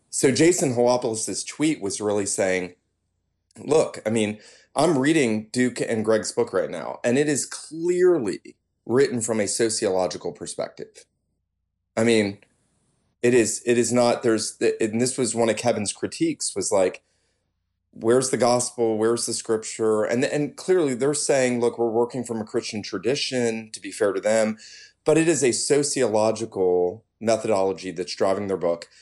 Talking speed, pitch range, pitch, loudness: 160 wpm, 105-125 Hz, 115 Hz, -23 LUFS